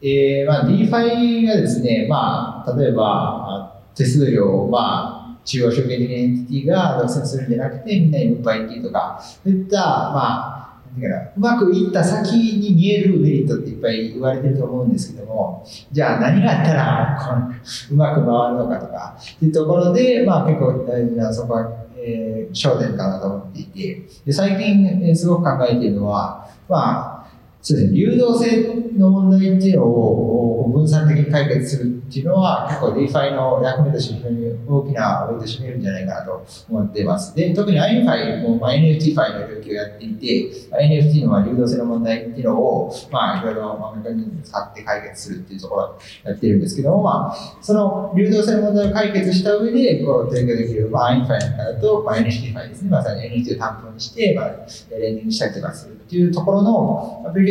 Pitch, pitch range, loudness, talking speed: 140 Hz, 115-190 Hz, -18 LUFS, 420 characters per minute